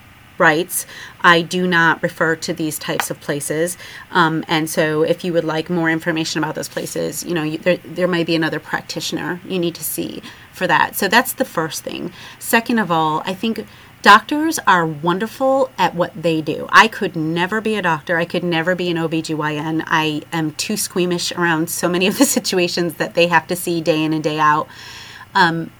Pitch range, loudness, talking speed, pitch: 160-180 Hz, -17 LUFS, 200 wpm, 170 Hz